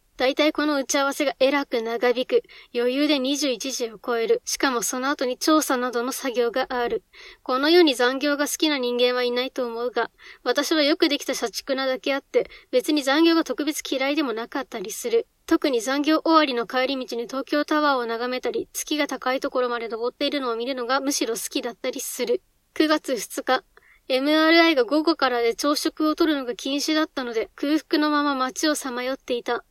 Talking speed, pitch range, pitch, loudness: 375 characters per minute, 250-310 Hz, 275 Hz, -23 LUFS